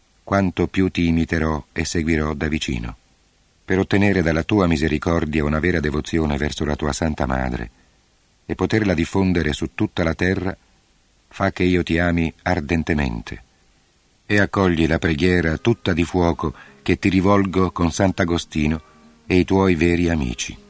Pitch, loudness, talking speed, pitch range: 85 Hz, -20 LUFS, 150 wpm, 80-95 Hz